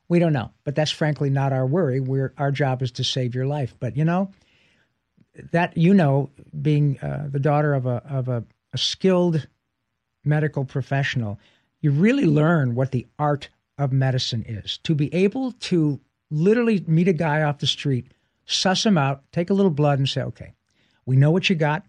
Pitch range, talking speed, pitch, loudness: 130-165 Hz, 190 wpm, 145 Hz, -22 LUFS